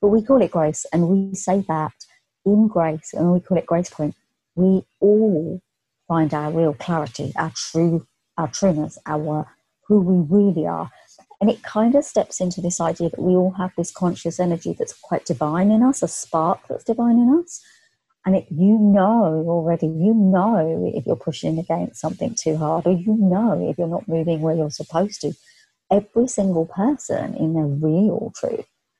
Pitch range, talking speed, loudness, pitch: 160-210 Hz, 185 wpm, -20 LUFS, 180 Hz